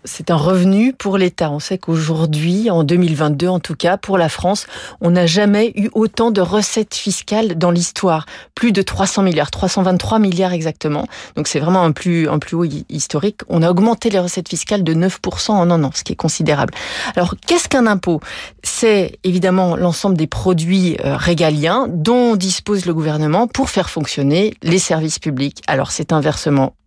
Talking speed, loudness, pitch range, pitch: 180 wpm, -16 LUFS, 160-200 Hz, 180 Hz